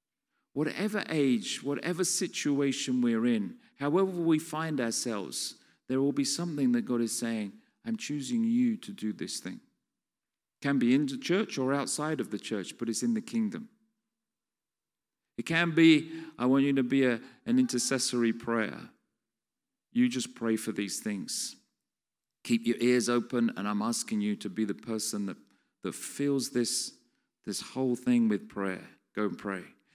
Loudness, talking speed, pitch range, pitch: -30 LUFS, 165 wpm, 115-195 Hz, 135 Hz